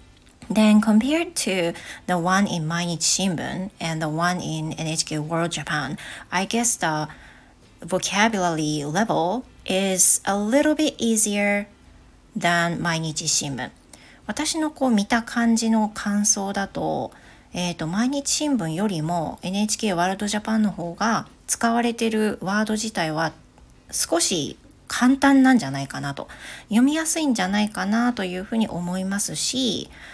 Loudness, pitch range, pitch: -22 LUFS, 170-230 Hz, 200 Hz